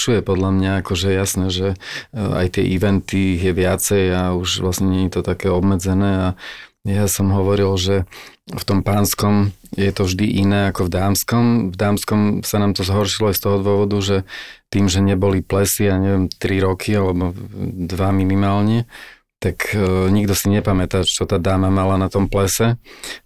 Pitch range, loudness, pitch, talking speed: 95-100 Hz, -18 LUFS, 95 Hz, 175 wpm